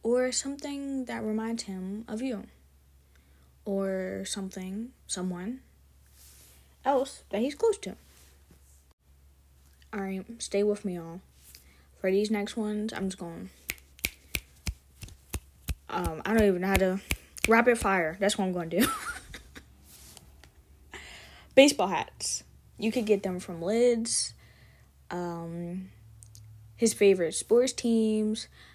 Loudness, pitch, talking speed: -29 LUFS, 180 Hz, 115 wpm